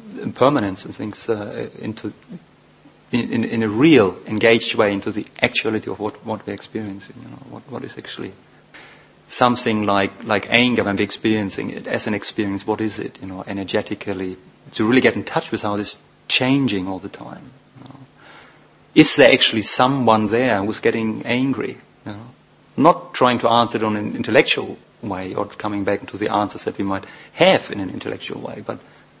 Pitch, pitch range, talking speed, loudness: 110 Hz, 100-115 Hz, 190 wpm, -19 LUFS